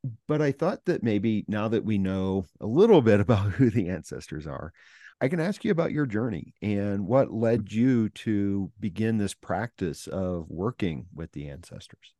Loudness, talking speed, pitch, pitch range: -26 LUFS, 180 wpm, 110 Hz, 100-125 Hz